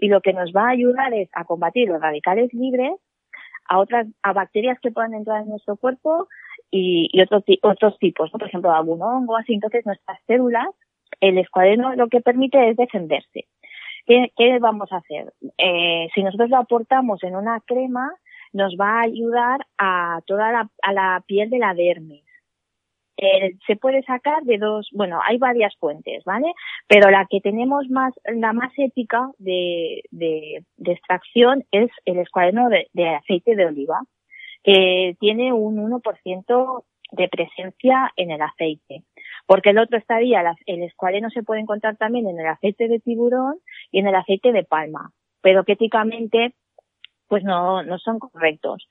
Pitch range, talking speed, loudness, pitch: 185-245 Hz, 170 wpm, -19 LUFS, 215 Hz